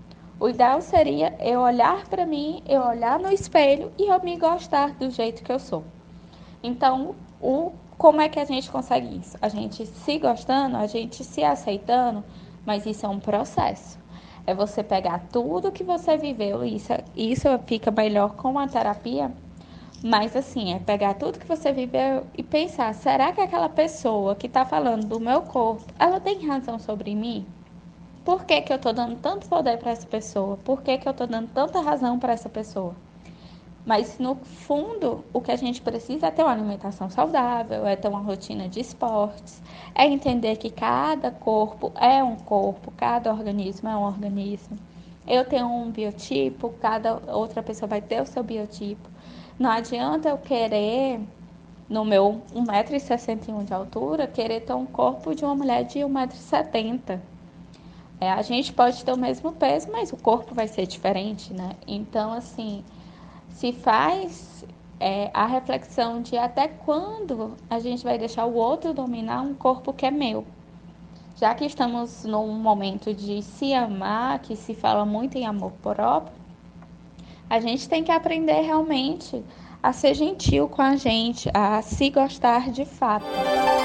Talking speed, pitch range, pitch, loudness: 170 wpm, 205-270 Hz, 235 Hz, -24 LUFS